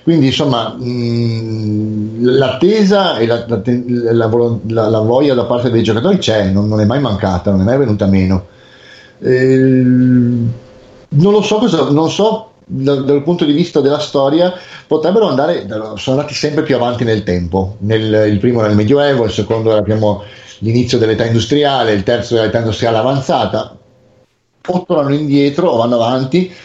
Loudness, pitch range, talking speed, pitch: -13 LUFS, 110-140 Hz, 160 wpm, 120 Hz